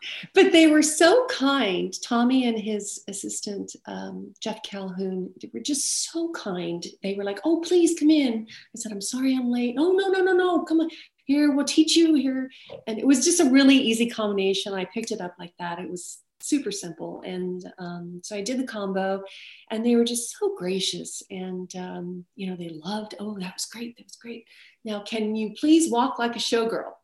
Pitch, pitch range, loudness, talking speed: 225 Hz, 190-285 Hz, -24 LUFS, 210 wpm